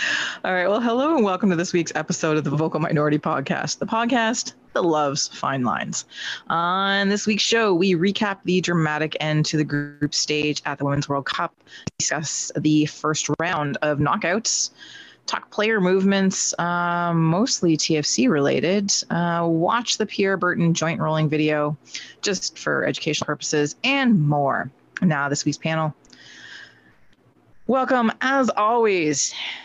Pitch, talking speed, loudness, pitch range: 170 Hz, 150 wpm, -21 LUFS, 150-200 Hz